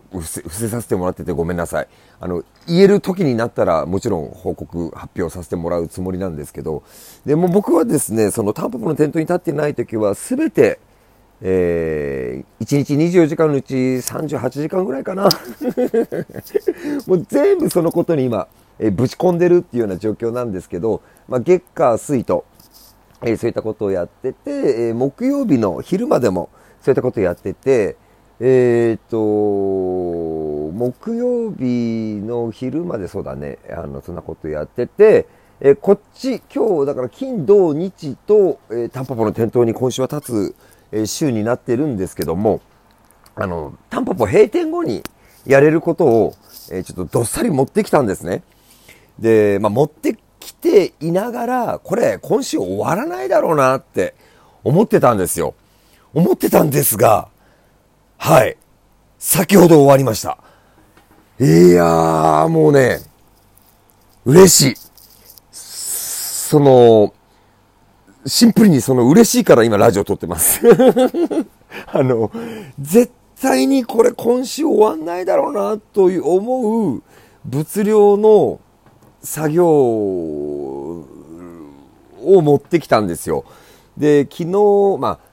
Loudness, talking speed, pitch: -16 LUFS, 280 characters per minute, 135 Hz